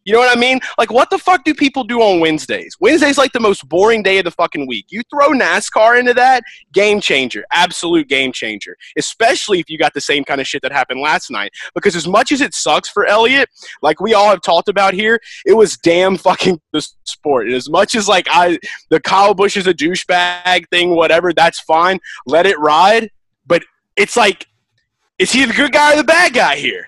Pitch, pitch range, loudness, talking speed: 200 Hz, 170-255 Hz, -13 LUFS, 225 wpm